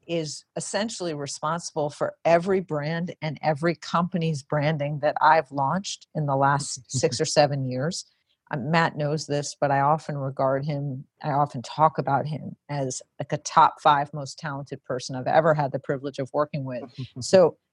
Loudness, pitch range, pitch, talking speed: -25 LUFS, 140-160 Hz, 150 Hz, 170 wpm